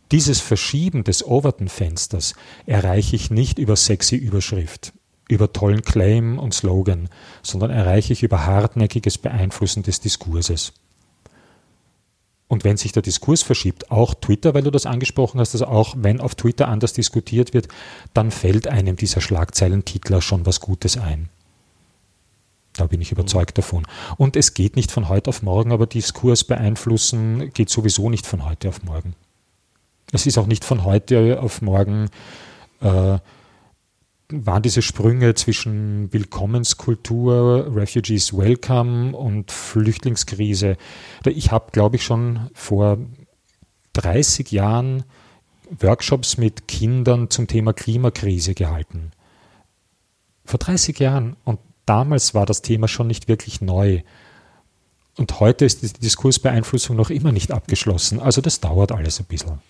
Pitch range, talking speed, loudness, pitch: 95-120 Hz, 135 wpm, -19 LUFS, 110 Hz